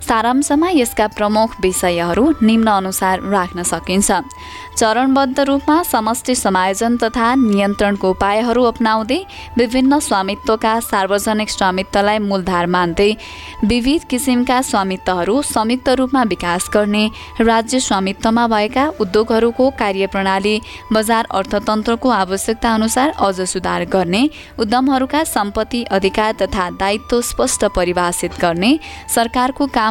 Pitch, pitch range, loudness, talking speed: 220 Hz, 195-245 Hz, -16 LUFS, 100 wpm